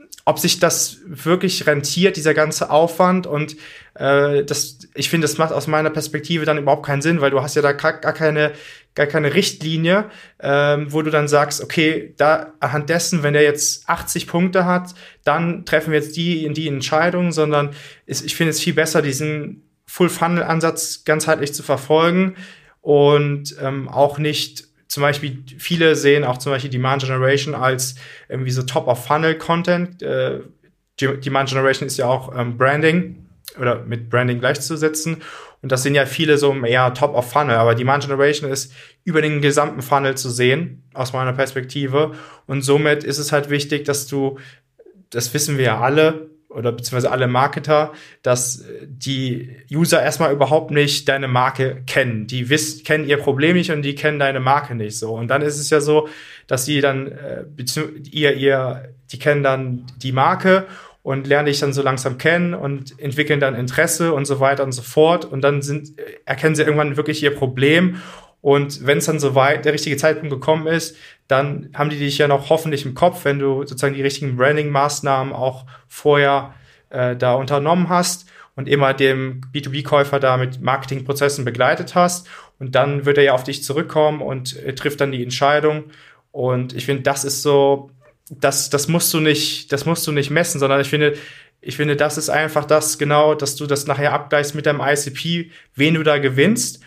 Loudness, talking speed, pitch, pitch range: -18 LUFS, 185 wpm, 145 Hz, 135-155 Hz